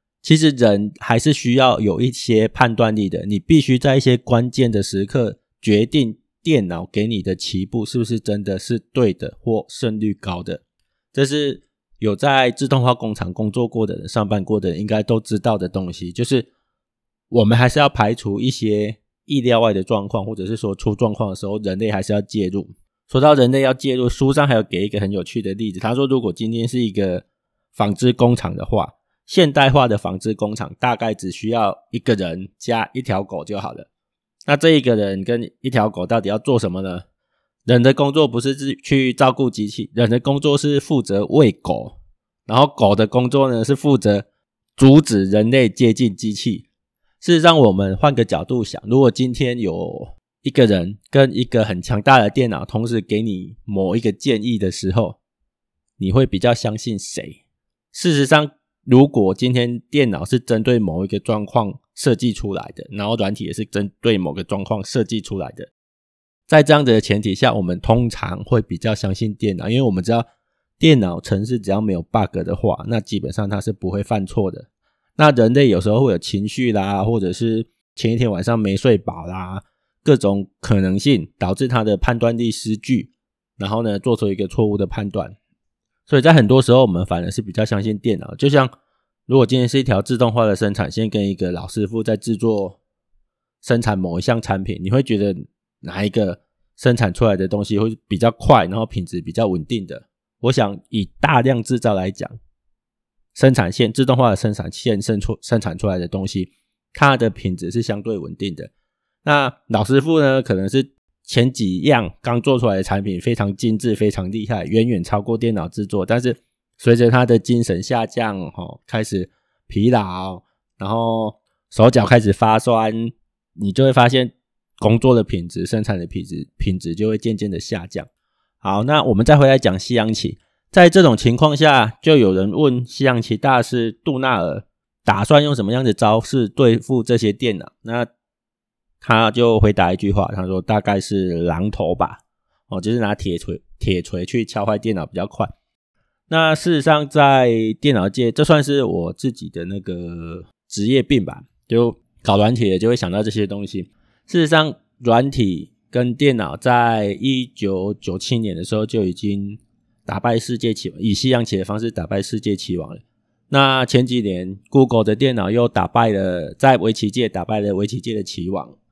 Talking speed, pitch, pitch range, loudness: 275 characters per minute, 110 Hz, 100-125 Hz, -18 LUFS